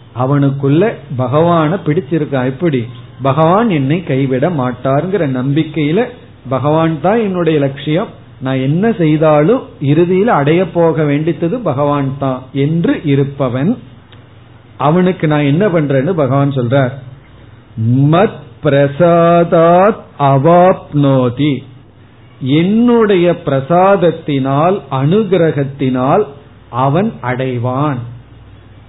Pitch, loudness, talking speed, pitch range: 145 Hz, -12 LUFS, 75 wpm, 130-170 Hz